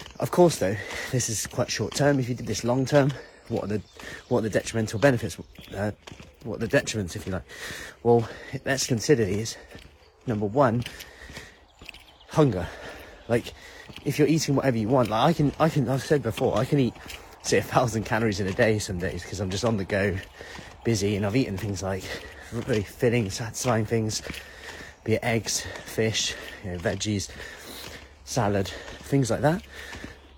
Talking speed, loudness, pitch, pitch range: 175 wpm, -26 LUFS, 110 Hz, 100-130 Hz